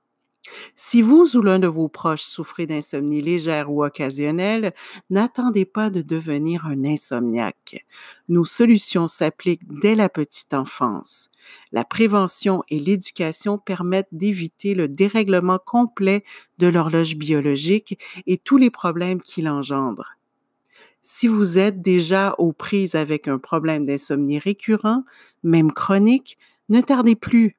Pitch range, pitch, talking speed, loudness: 155-210 Hz, 185 Hz, 130 wpm, -19 LUFS